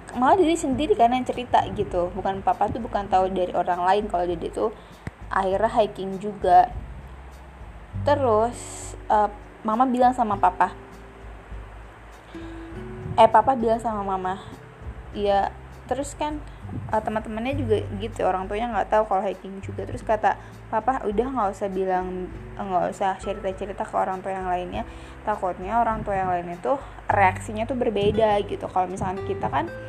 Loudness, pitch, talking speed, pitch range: -24 LUFS, 195 Hz, 155 wpm, 180-225 Hz